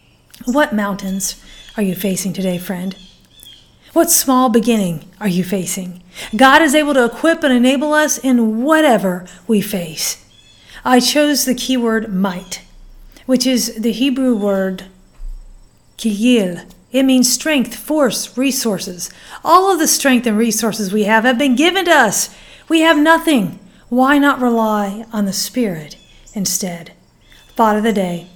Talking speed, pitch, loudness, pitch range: 145 wpm, 230 Hz, -15 LUFS, 190-265 Hz